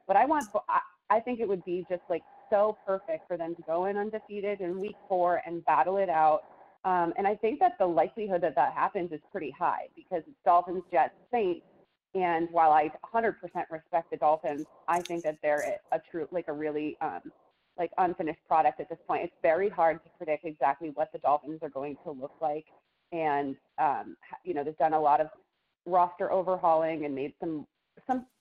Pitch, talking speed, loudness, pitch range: 170 Hz, 200 wpm, -30 LUFS, 155-195 Hz